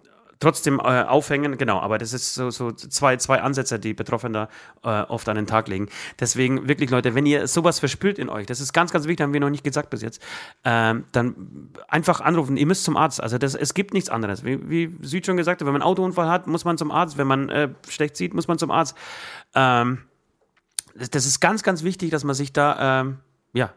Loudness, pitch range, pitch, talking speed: -22 LUFS, 125-160 Hz, 140 Hz, 230 wpm